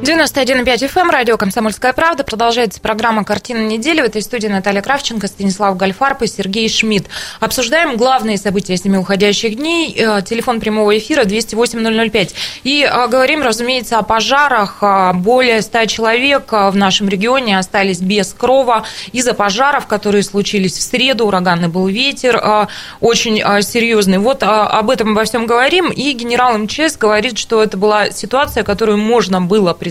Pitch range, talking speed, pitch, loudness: 205-250 Hz, 150 wpm, 225 Hz, -13 LUFS